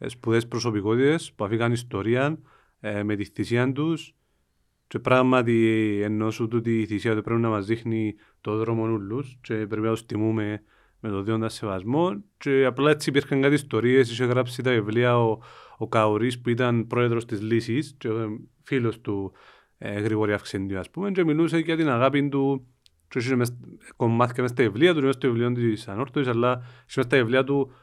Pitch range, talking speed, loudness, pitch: 110-135 Hz, 175 wpm, -24 LUFS, 120 Hz